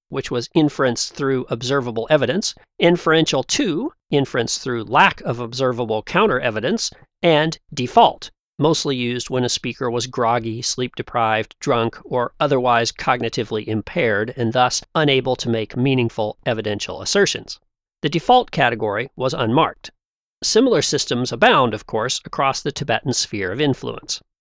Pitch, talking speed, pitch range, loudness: 125 Hz, 130 wpm, 115-150 Hz, -19 LUFS